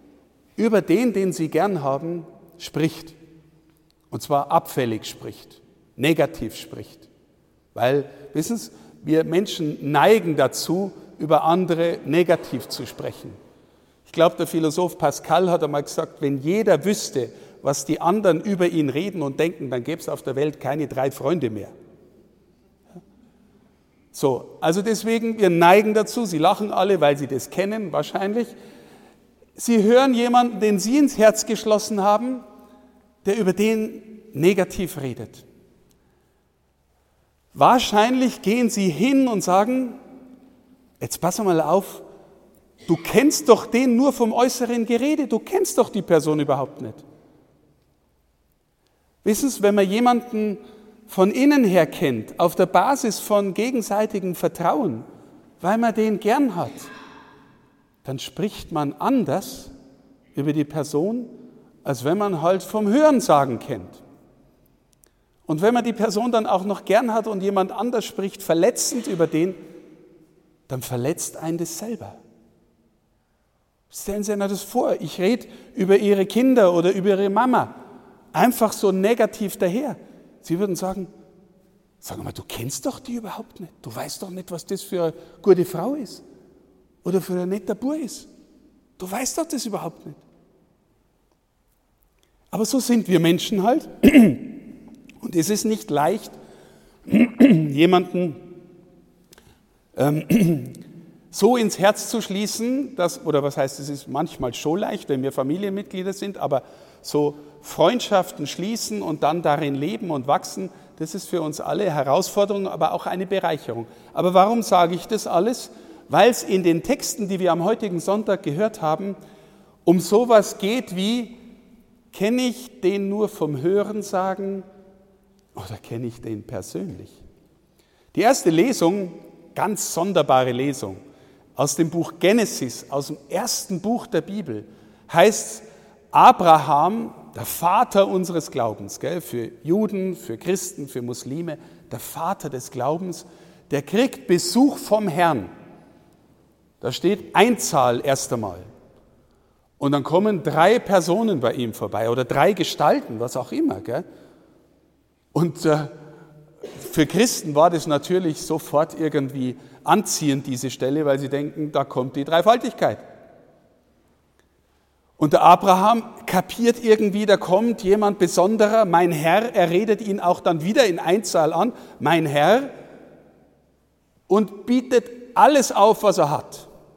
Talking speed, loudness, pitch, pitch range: 135 wpm, -21 LUFS, 185 Hz, 150-215 Hz